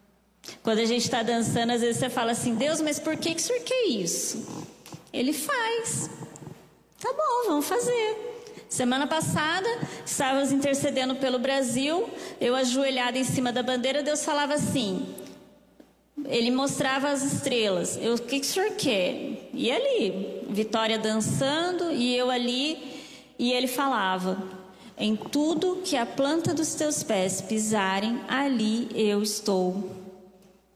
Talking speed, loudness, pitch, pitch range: 140 wpm, -26 LUFS, 260 Hz, 225-300 Hz